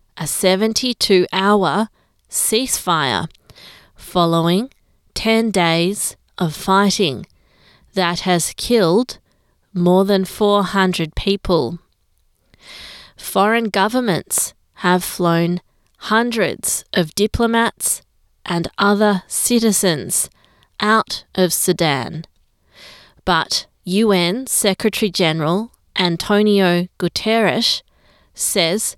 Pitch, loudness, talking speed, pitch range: 195 Hz, -17 LUFS, 70 wpm, 175-220 Hz